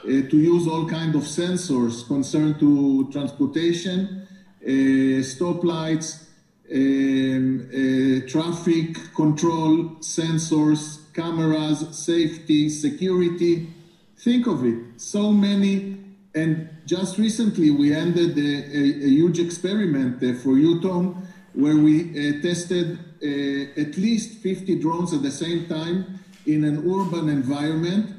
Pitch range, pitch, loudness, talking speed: 145-175 Hz, 160 Hz, -22 LUFS, 115 wpm